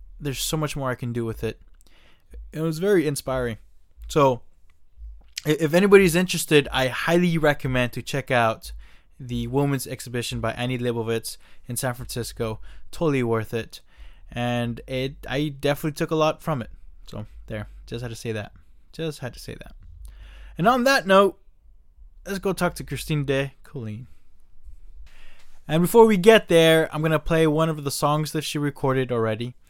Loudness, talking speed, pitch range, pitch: -23 LUFS, 170 wpm, 100-155 Hz, 125 Hz